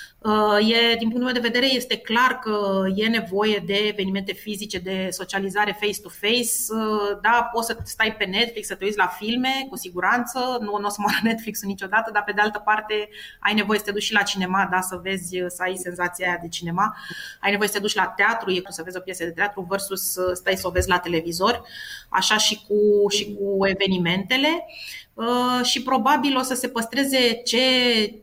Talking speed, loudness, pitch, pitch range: 200 wpm, -22 LUFS, 210 Hz, 195-230 Hz